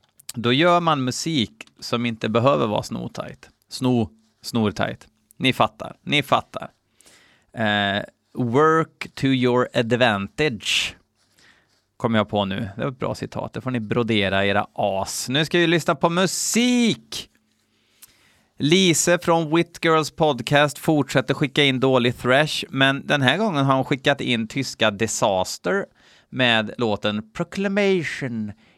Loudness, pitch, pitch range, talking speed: -21 LUFS, 130 Hz, 110-160 Hz, 130 wpm